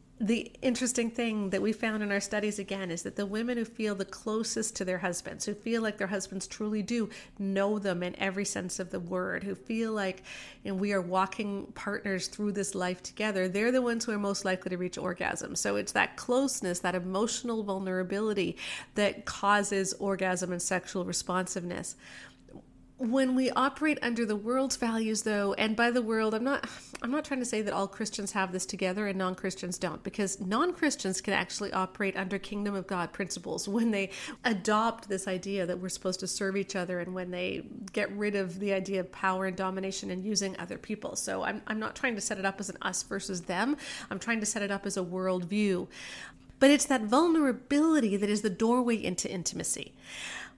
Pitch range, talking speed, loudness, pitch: 190-225 Hz, 200 wpm, -31 LUFS, 200 Hz